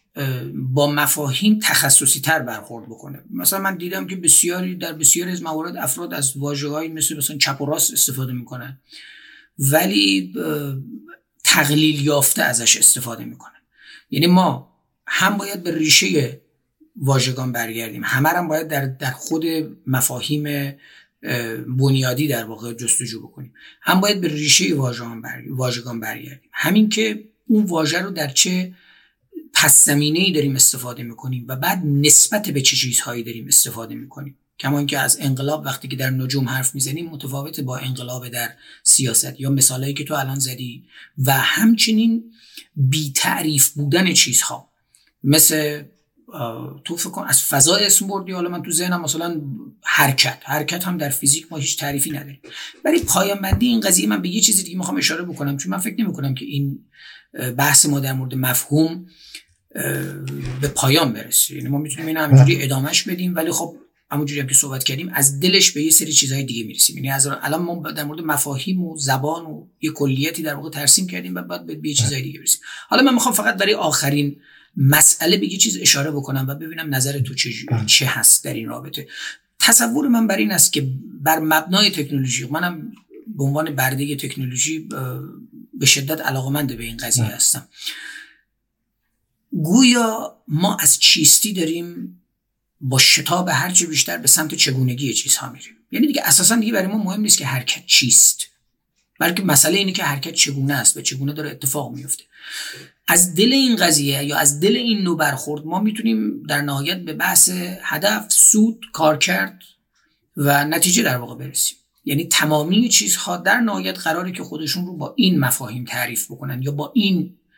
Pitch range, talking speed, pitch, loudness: 135-170 Hz, 165 wpm, 150 Hz, -17 LUFS